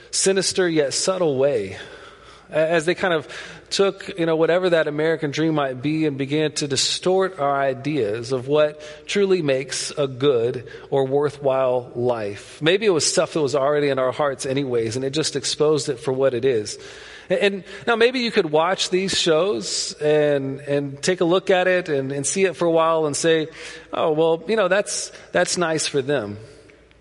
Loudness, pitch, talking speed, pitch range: -21 LUFS, 155 Hz, 190 wpm, 140-185 Hz